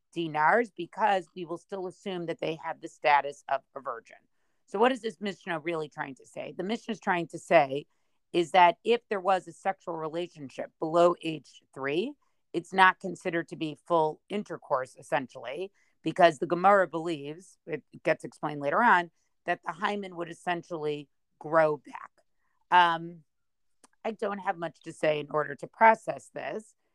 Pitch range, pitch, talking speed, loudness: 155-185 Hz, 170 Hz, 170 wpm, -28 LUFS